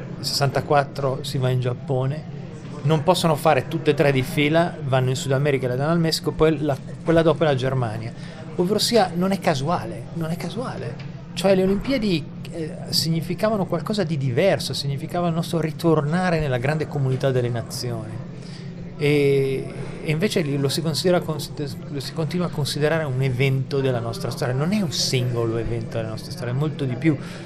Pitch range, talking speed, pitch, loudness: 135-165 Hz, 180 wpm, 155 Hz, -22 LUFS